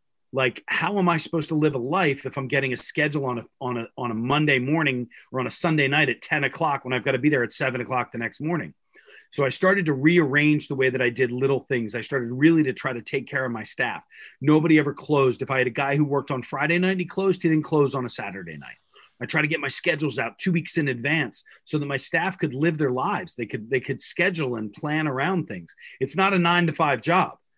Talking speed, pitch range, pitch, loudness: 265 wpm, 130-160 Hz, 140 Hz, -23 LUFS